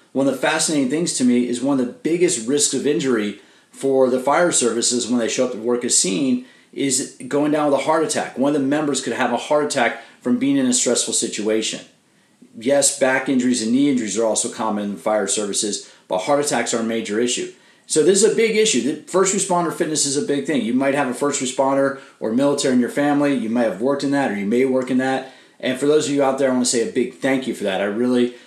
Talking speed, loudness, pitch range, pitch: 260 wpm, -19 LUFS, 120-150 Hz, 135 Hz